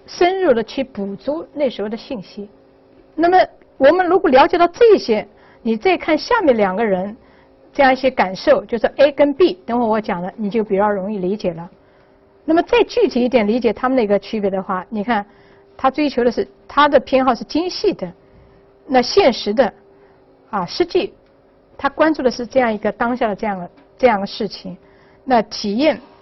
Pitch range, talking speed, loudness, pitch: 210-295 Hz, 270 characters per minute, -17 LUFS, 245 Hz